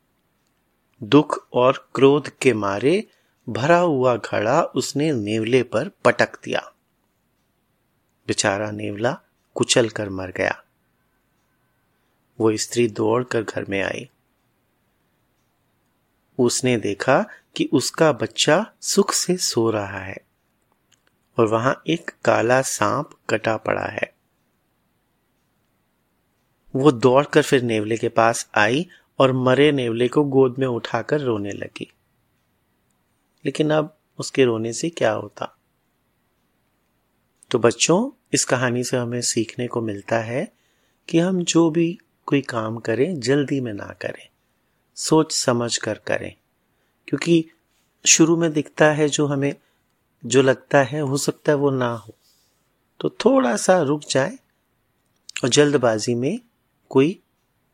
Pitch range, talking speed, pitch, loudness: 115-150 Hz, 120 wpm, 130 Hz, -20 LUFS